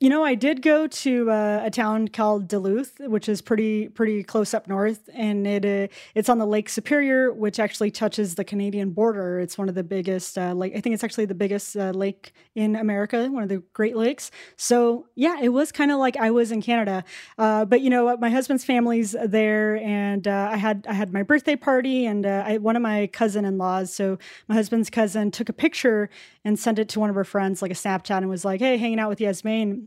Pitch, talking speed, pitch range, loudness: 215 Hz, 235 wpm, 200-235 Hz, -23 LUFS